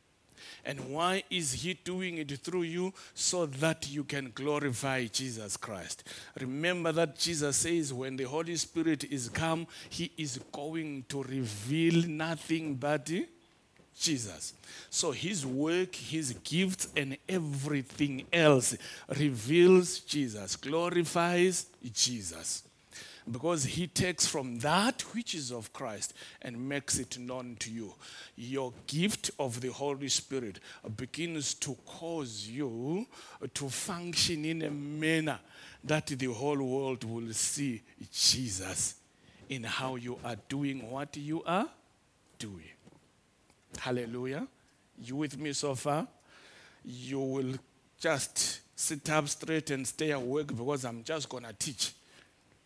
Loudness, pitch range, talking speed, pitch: -33 LUFS, 130-160 Hz, 130 wpm, 145 Hz